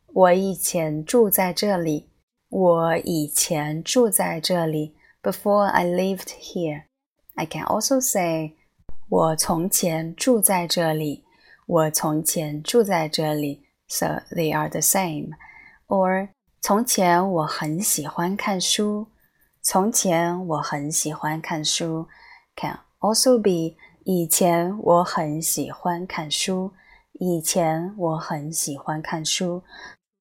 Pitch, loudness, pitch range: 170 Hz, -22 LUFS, 160-190 Hz